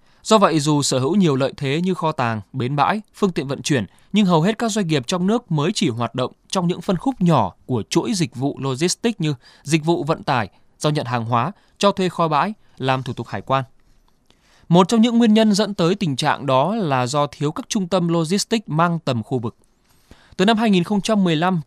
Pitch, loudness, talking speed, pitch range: 165 Hz, -20 LUFS, 225 wpm, 135-200 Hz